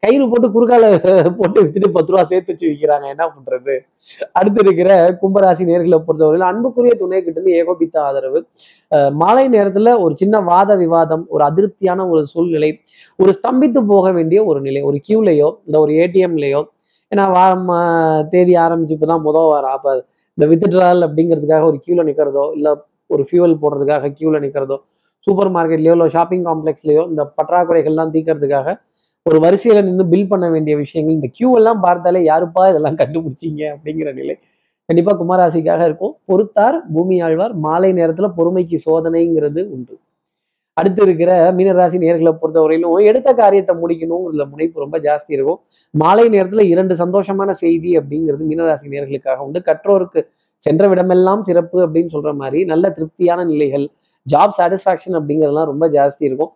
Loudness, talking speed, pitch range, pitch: -13 LUFS, 140 wpm, 155-190 Hz, 170 Hz